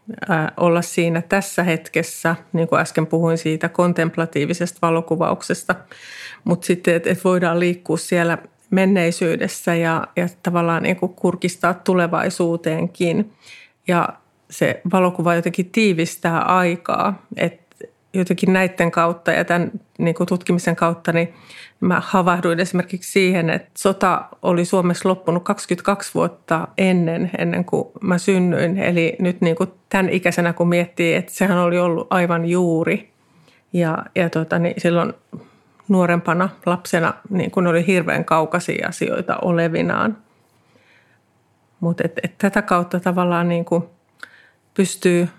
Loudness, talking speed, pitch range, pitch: -19 LUFS, 125 wpm, 170-185 Hz, 175 Hz